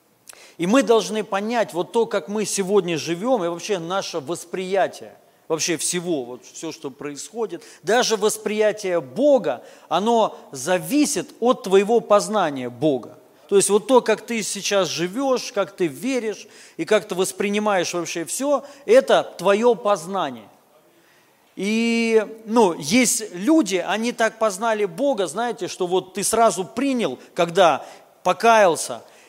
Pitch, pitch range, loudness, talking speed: 205 Hz, 180-230 Hz, -21 LUFS, 135 wpm